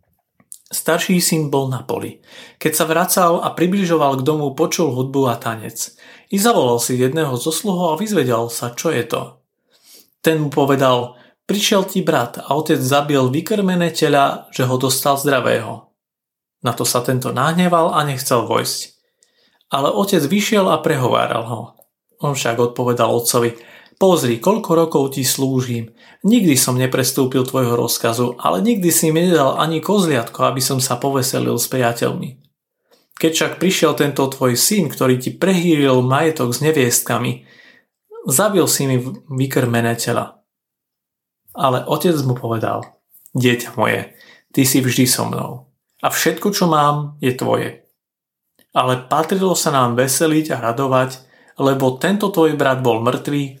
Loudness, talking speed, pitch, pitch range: -17 LUFS, 145 wpm, 140 Hz, 125-165 Hz